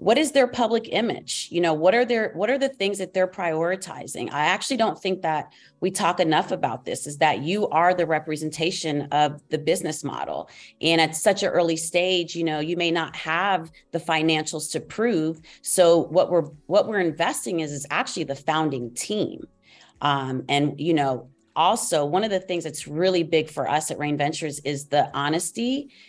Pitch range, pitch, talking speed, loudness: 150-185 Hz, 165 Hz, 195 wpm, -23 LUFS